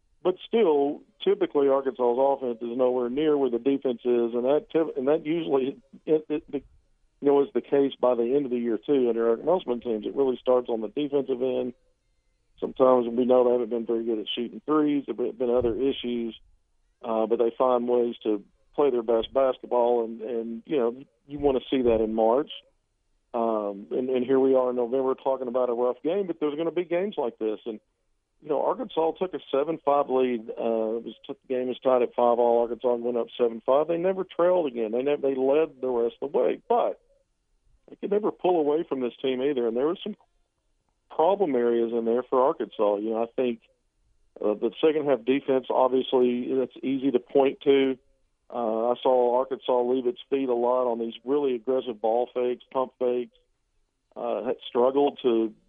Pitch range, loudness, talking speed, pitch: 120-140 Hz, -26 LUFS, 205 wpm, 125 Hz